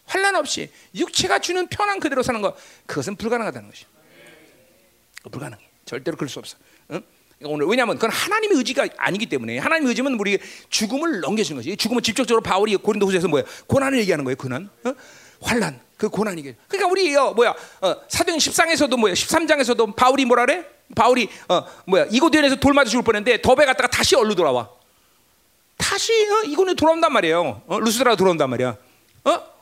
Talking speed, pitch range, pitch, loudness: 425 characters per minute, 195-320 Hz, 245 Hz, -20 LUFS